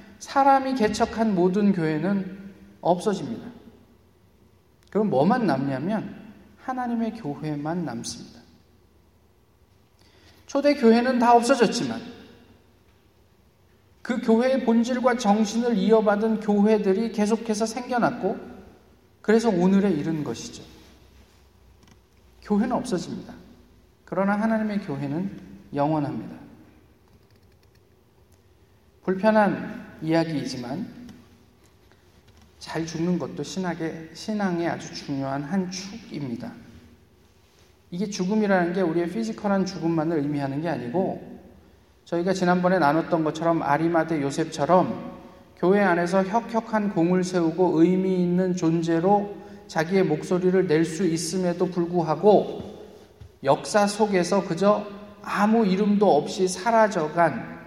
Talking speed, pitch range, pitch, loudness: 250 characters per minute, 145-215 Hz, 180 Hz, -23 LUFS